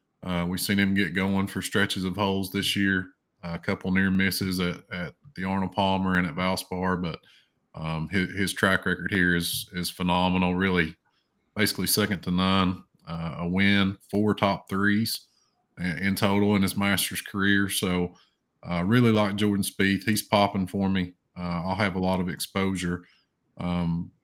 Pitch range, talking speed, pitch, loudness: 90-100 Hz, 180 wpm, 95 Hz, -26 LUFS